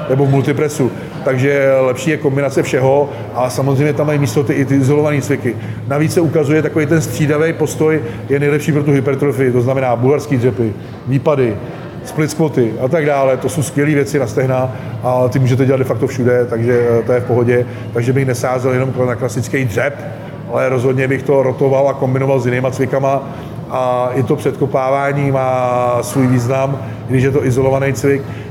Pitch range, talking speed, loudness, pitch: 125-145 Hz, 180 wpm, -15 LUFS, 135 Hz